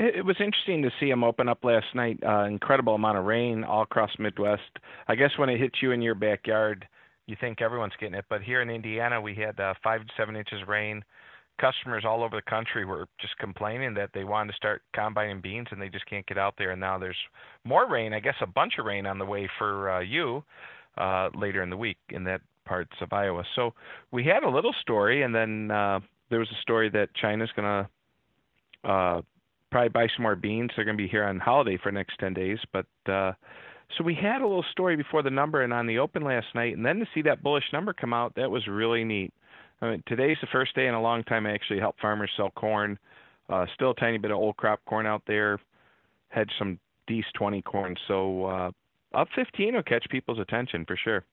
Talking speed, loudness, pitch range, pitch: 235 wpm, -28 LUFS, 100-120 Hz, 110 Hz